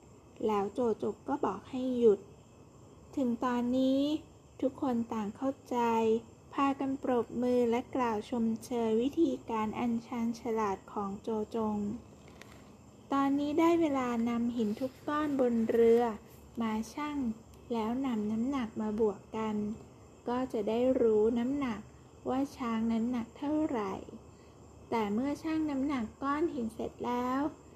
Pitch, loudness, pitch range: 240 Hz, -32 LUFS, 225-270 Hz